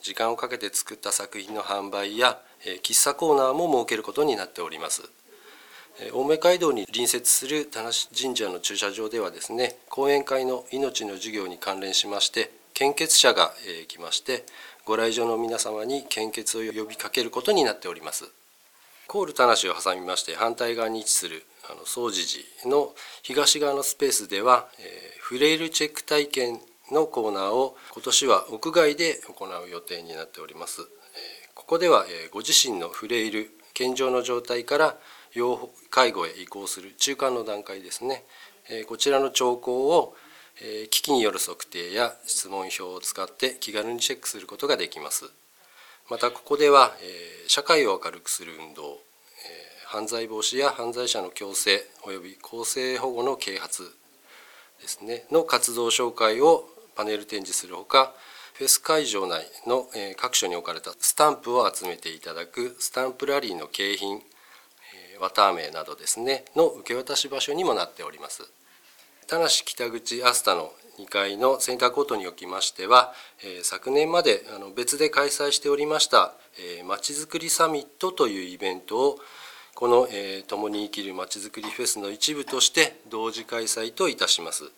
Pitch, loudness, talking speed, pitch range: 125 Hz, -24 LUFS, 320 characters per minute, 110-160 Hz